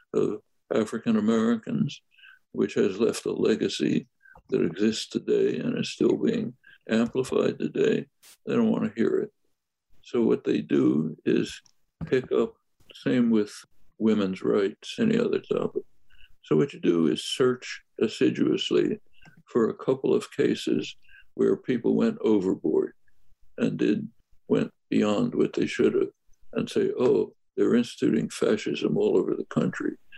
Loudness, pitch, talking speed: -26 LUFS, 370 Hz, 140 wpm